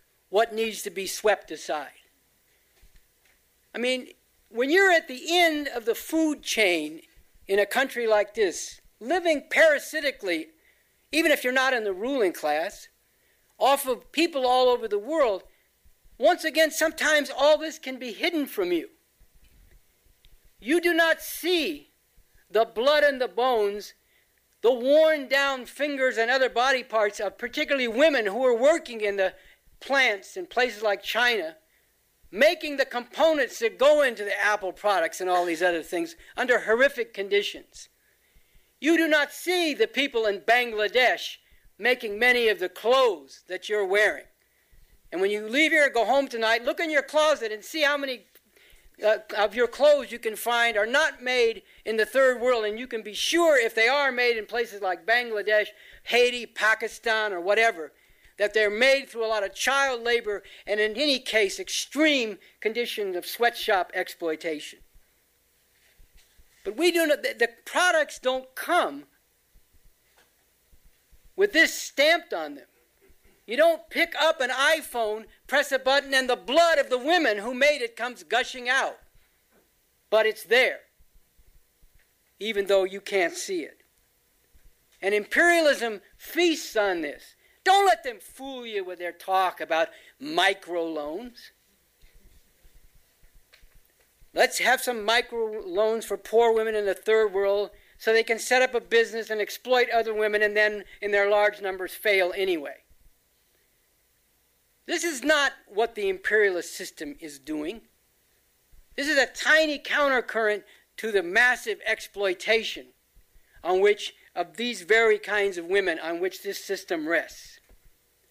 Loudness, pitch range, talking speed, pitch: -24 LUFS, 210-300 Hz, 150 wpm, 245 Hz